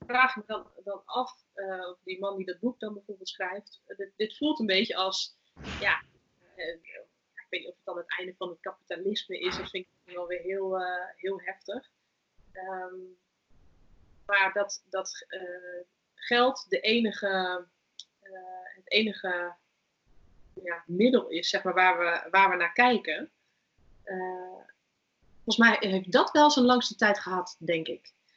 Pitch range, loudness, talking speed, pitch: 180-210 Hz, -28 LUFS, 165 wpm, 190 Hz